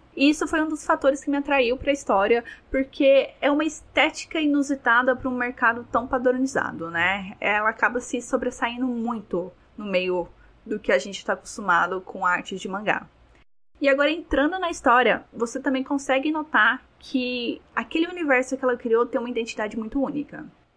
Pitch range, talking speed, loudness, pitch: 225-280 Hz, 170 wpm, -23 LUFS, 255 Hz